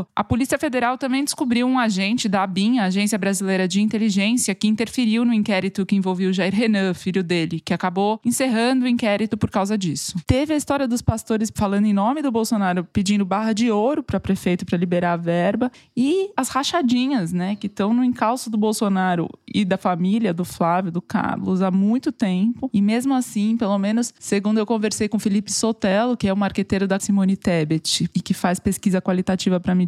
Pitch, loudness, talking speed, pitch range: 205 Hz, -21 LUFS, 200 wpm, 190-235 Hz